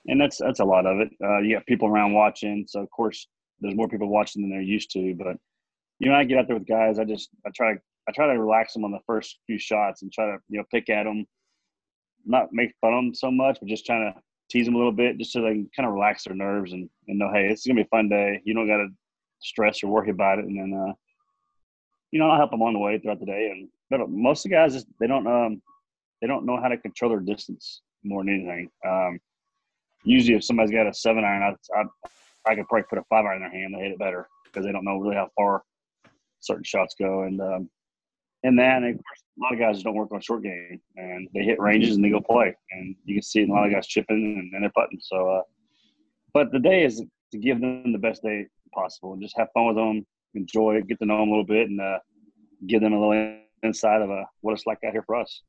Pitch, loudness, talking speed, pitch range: 105 Hz, -24 LUFS, 270 wpm, 100-115 Hz